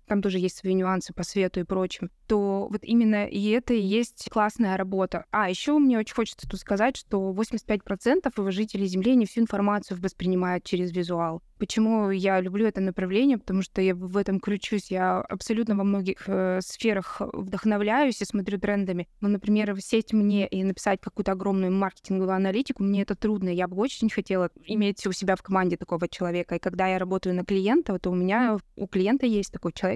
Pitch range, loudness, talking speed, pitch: 185-215 Hz, -26 LUFS, 190 wpm, 200 Hz